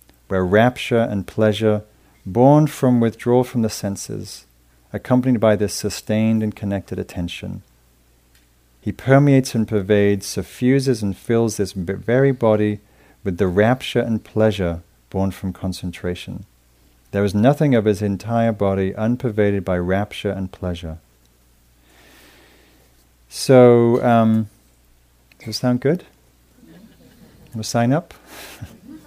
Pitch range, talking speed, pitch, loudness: 85-115 Hz, 120 wpm, 100 Hz, -19 LUFS